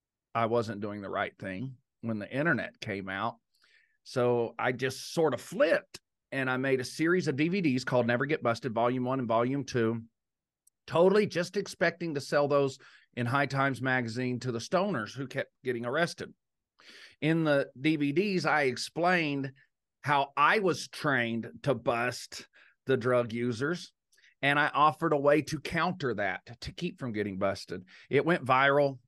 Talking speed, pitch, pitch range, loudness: 165 wpm, 130 Hz, 120-150 Hz, -30 LUFS